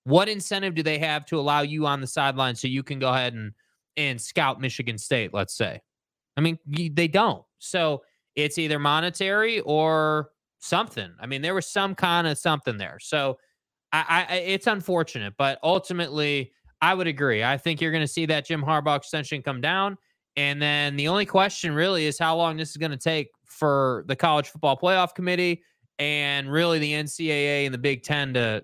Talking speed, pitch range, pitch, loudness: 195 wpm, 140-170 Hz, 150 Hz, -24 LUFS